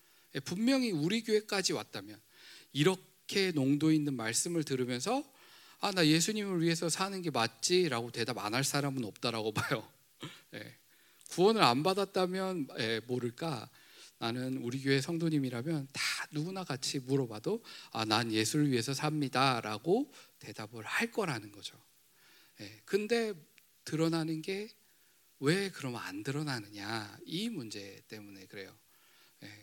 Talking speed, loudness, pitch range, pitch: 275 characters per minute, -33 LUFS, 120-185 Hz, 145 Hz